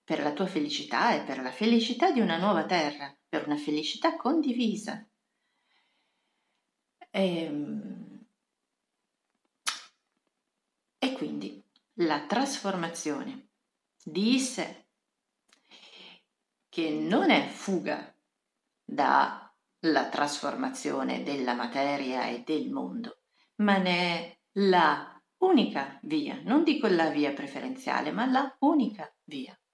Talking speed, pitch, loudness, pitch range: 100 wpm, 205 Hz, -29 LUFS, 155-255 Hz